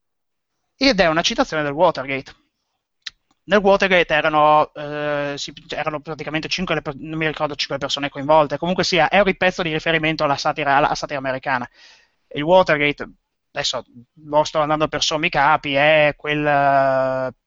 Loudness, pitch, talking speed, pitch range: -18 LUFS, 150 Hz, 155 wpm, 145-160 Hz